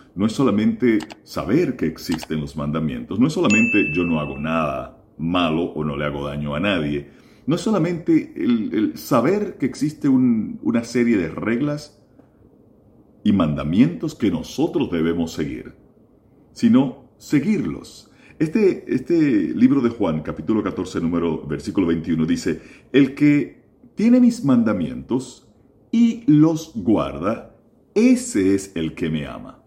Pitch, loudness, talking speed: 125 Hz, -20 LUFS, 140 wpm